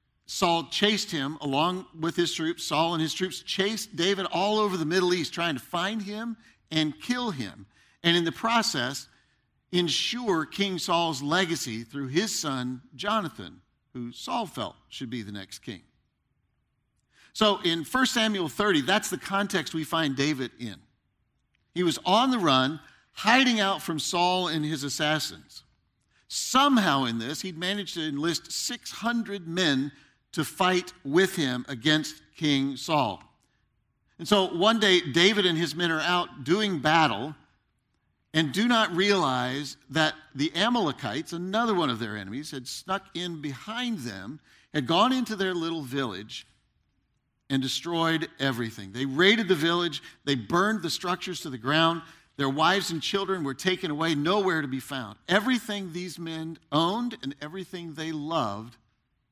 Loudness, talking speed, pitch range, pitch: -26 LUFS, 155 wpm, 140-190 Hz, 165 Hz